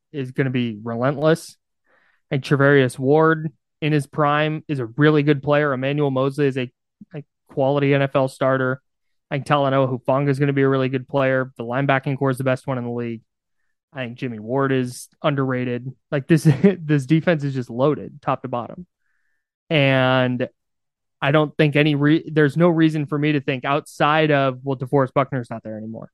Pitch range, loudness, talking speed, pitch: 130-150 Hz, -20 LUFS, 200 wpm, 140 Hz